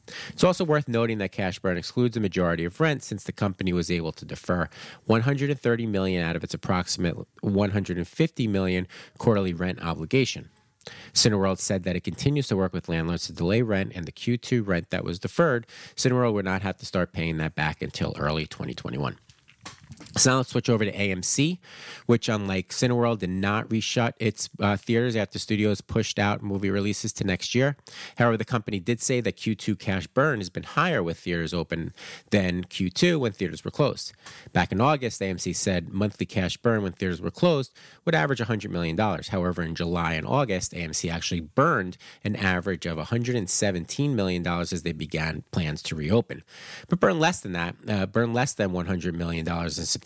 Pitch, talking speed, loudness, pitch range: 100 Hz, 185 wpm, -26 LUFS, 90-120 Hz